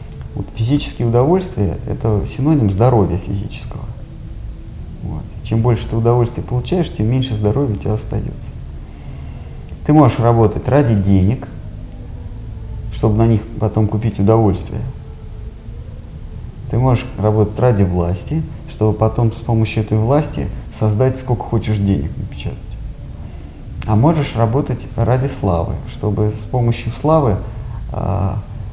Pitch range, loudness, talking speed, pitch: 105-120 Hz, -17 LUFS, 115 wpm, 110 Hz